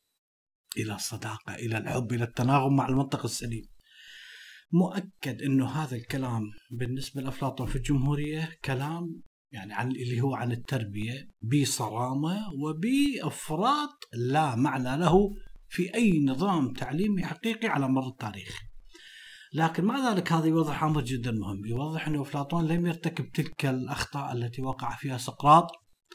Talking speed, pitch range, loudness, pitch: 130 wpm, 125-165 Hz, -29 LUFS, 140 Hz